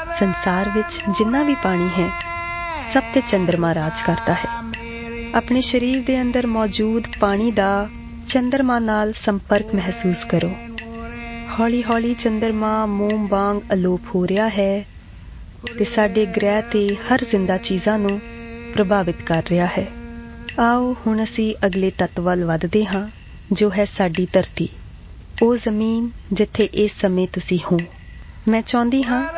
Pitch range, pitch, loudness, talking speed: 190-235 Hz, 215 Hz, -20 LUFS, 135 wpm